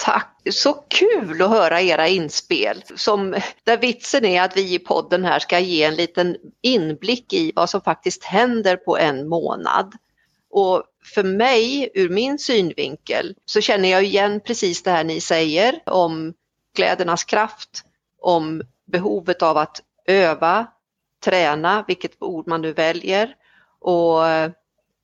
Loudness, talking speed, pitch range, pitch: -19 LUFS, 140 wpm, 165-225 Hz, 185 Hz